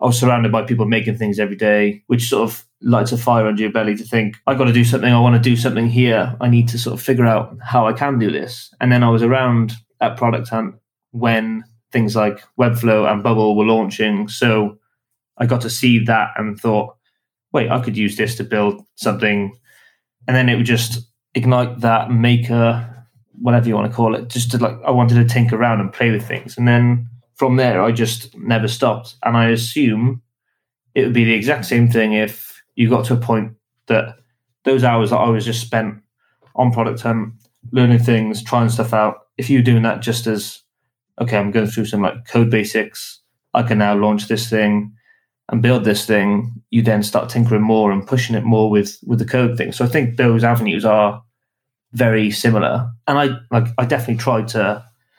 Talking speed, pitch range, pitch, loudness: 210 wpm, 110-120 Hz, 115 Hz, -16 LUFS